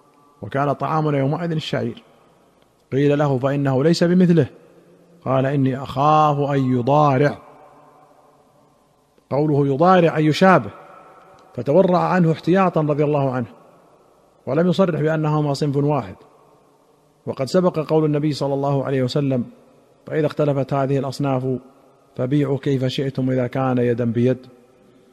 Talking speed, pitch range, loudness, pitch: 115 wpm, 135-155 Hz, -19 LUFS, 145 Hz